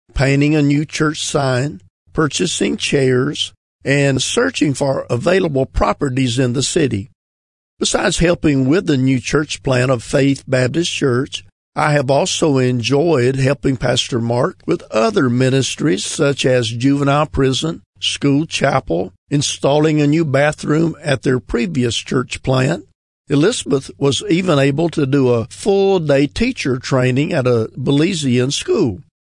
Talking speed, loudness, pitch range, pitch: 135 wpm, -16 LUFS, 125-150 Hz, 140 Hz